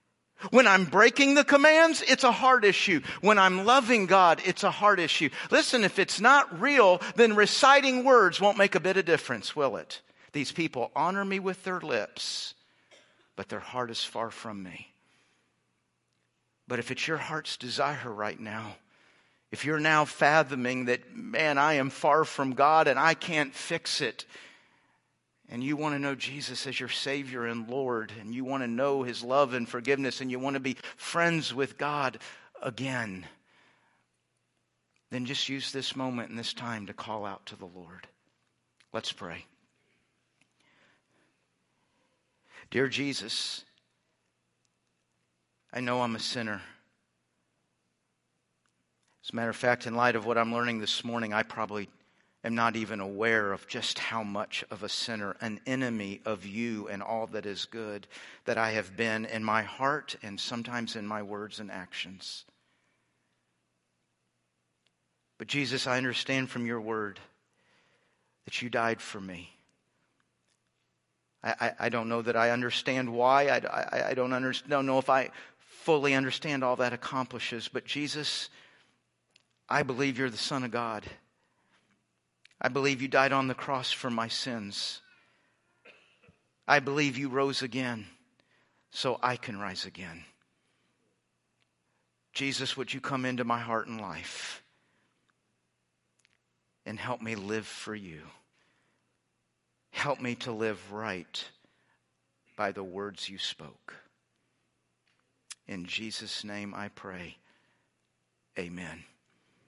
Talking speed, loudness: 145 wpm, -28 LUFS